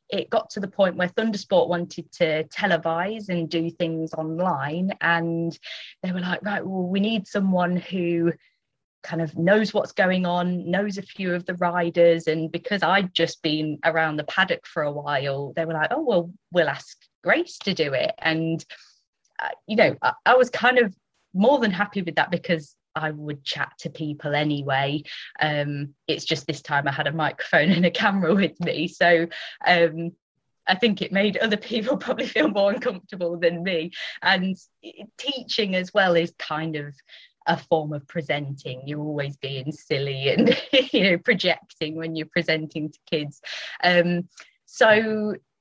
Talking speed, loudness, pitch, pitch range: 175 wpm, -23 LUFS, 170 Hz, 155-195 Hz